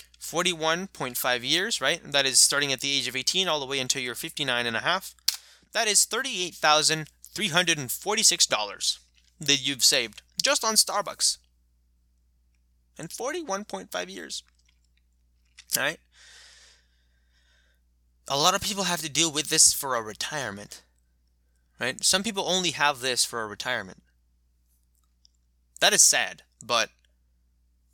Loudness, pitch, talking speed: -24 LUFS, 120 Hz, 125 wpm